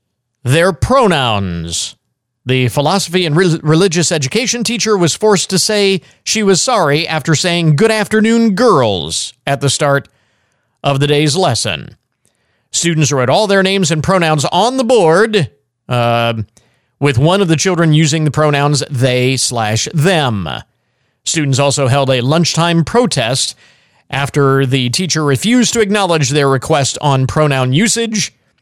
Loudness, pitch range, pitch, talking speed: -12 LUFS, 130-185 Hz, 150 Hz, 140 wpm